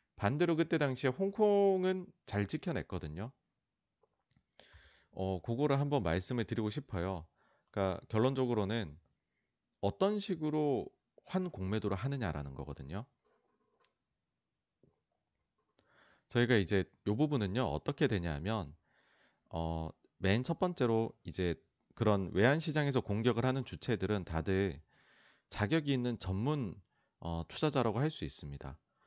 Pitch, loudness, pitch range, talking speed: 110 Hz, -35 LUFS, 95-140 Hz, 255 characters per minute